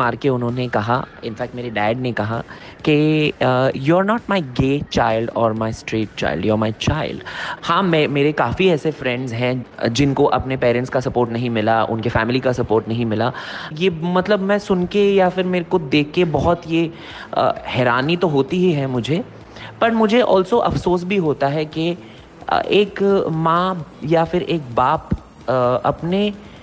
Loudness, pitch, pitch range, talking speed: -19 LUFS, 145 Hz, 120-180 Hz, 185 wpm